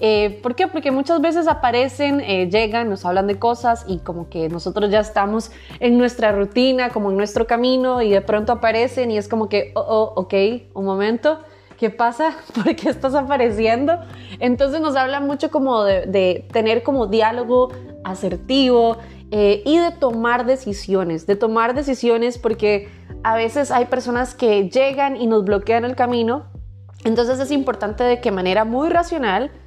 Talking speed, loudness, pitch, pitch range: 170 wpm, -19 LUFS, 235 Hz, 205-260 Hz